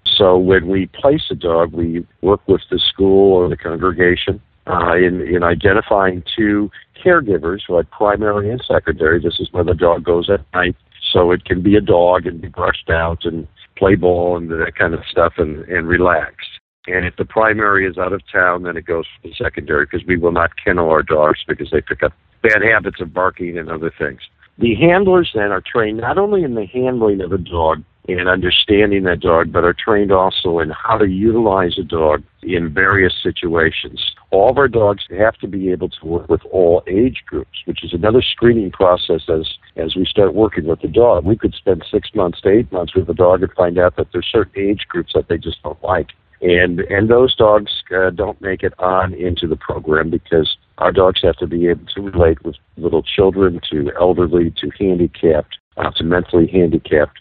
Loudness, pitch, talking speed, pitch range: -15 LUFS, 90 Hz, 210 wpm, 85-100 Hz